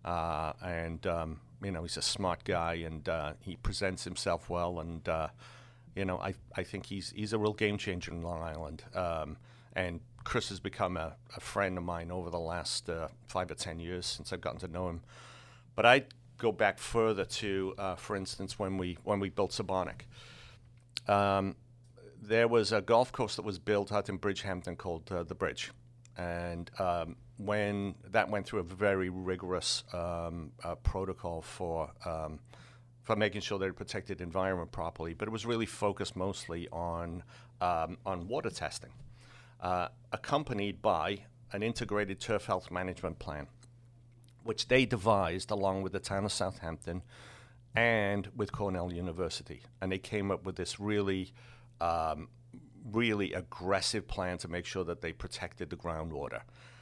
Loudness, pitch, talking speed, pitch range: -35 LUFS, 95 Hz, 170 wpm, 90-115 Hz